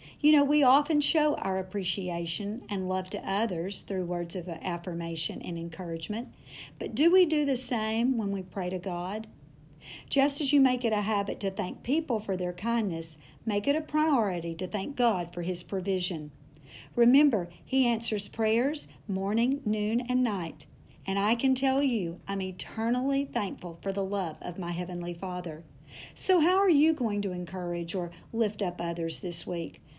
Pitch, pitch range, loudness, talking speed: 195 Hz, 175-240 Hz, -29 LUFS, 175 wpm